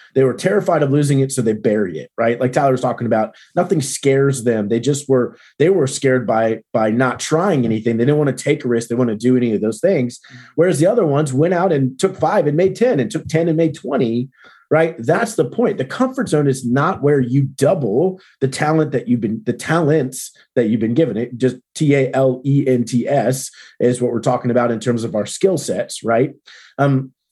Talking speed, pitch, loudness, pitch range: 240 wpm, 135 Hz, -17 LUFS, 120-150 Hz